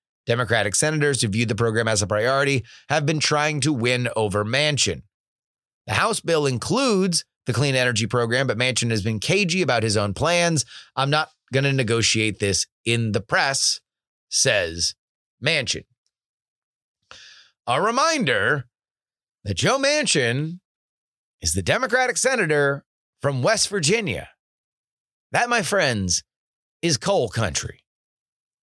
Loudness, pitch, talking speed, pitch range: -21 LUFS, 130 Hz, 130 wpm, 110-155 Hz